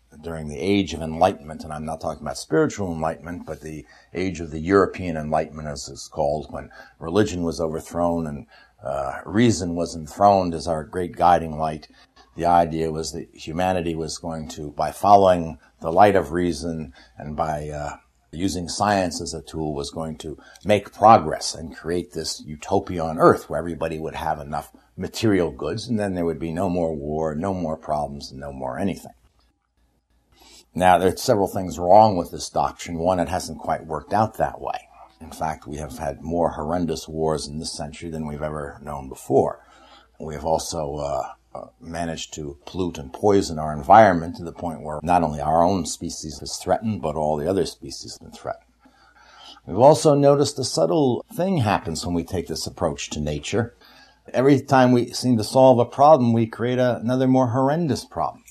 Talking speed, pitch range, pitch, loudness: 185 wpm, 80-95 Hz, 85 Hz, -22 LUFS